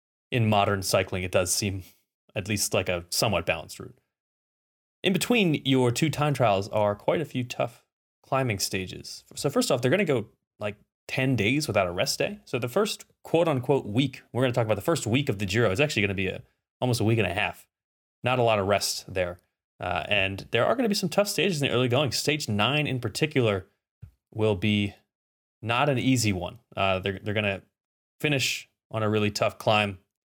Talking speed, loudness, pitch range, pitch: 210 wpm, -26 LUFS, 100-135 Hz, 110 Hz